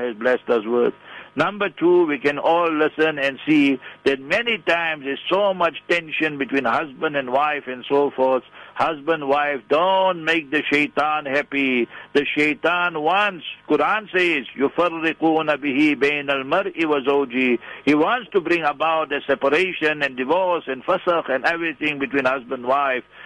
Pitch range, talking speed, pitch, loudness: 140-165 Hz, 150 wpm, 150 Hz, -20 LUFS